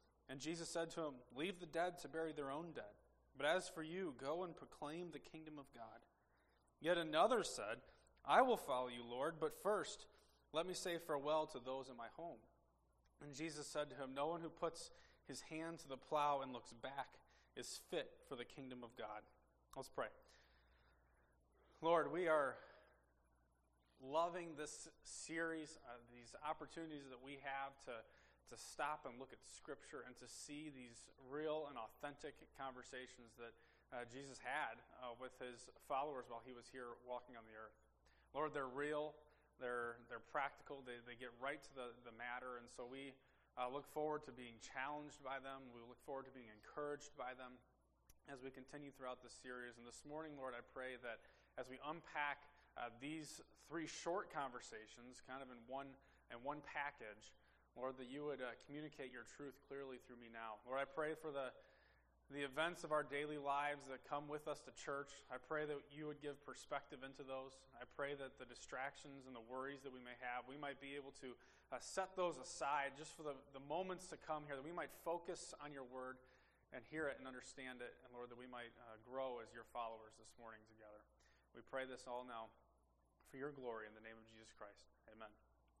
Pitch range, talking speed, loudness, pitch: 120-150 Hz, 195 wpm, -48 LUFS, 130 Hz